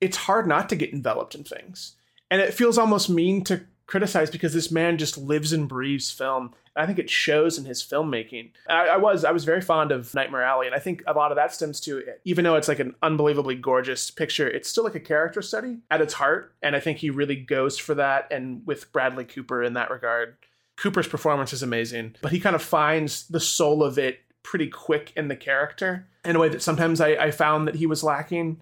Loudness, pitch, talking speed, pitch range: -24 LUFS, 150 Hz, 235 wpm, 135-165 Hz